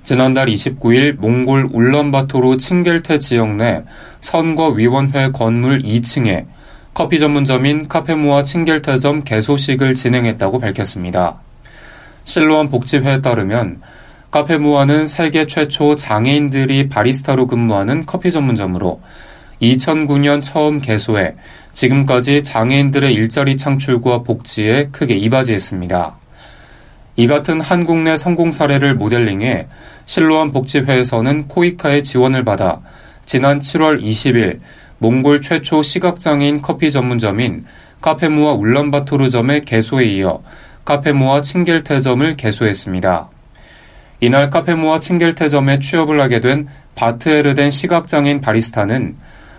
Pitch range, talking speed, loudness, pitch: 115-150 Hz, 295 characters per minute, -14 LUFS, 135 Hz